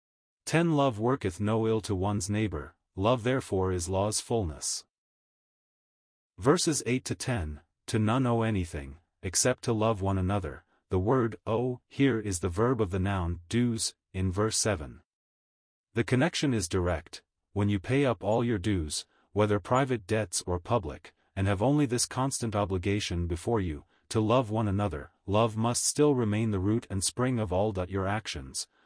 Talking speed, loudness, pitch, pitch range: 165 wpm, -29 LUFS, 105 Hz, 95-120 Hz